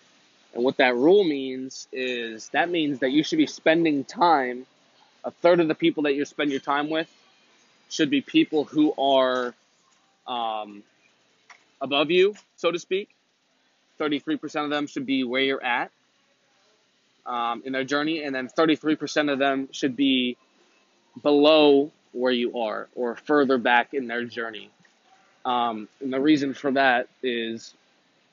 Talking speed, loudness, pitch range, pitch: 155 wpm, -24 LUFS, 125-155 Hz, 140 Hz